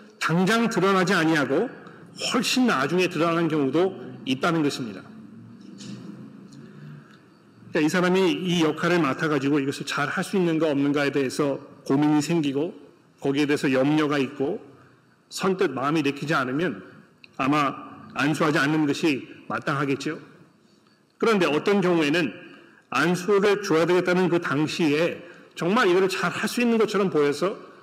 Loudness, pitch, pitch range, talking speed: -23 LUFS, 160 Hz, 145-180 Hz, 305 characters per minute